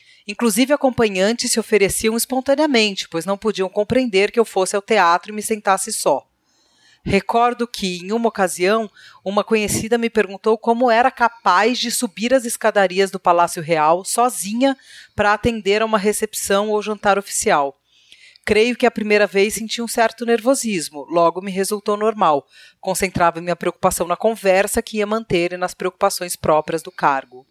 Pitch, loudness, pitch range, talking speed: 210 Hz, -18 LUFS, 190-230 Hz, 160 wpm